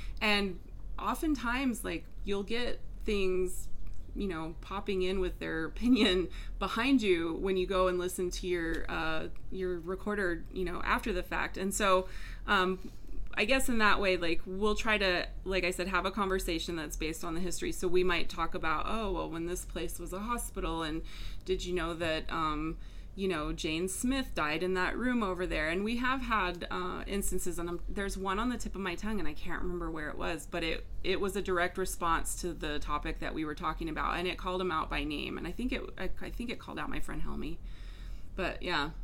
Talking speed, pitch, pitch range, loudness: 220 wpm, 185 Hz, 170-200 Hz, -33 LUFS